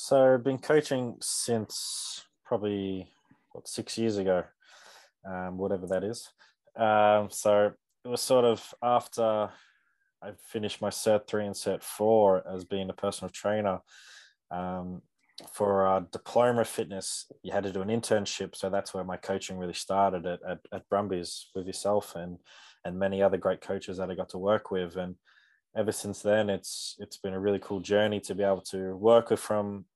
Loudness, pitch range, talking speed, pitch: -29 LUFS, 95-105 Hz, 180 wpm, 100 Hz